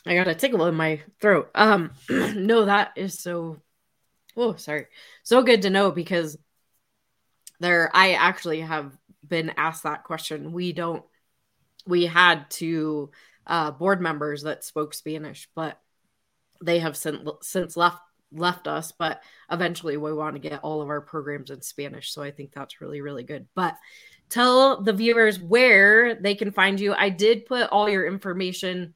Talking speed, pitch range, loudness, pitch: 170 wpm, 155-195 Hz, -22 LUFS, 170 Hz